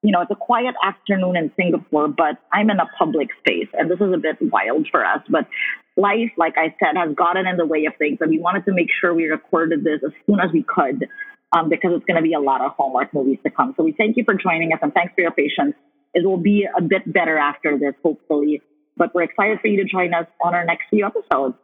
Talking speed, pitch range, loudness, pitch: 265 wpm, 160-200 Hz, -19 LUFS, 175 Hz